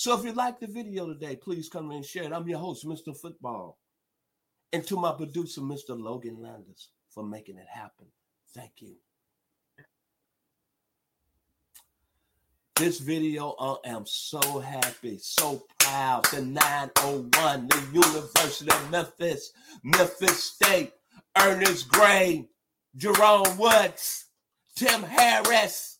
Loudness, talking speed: -24 LUFS, 120 wpm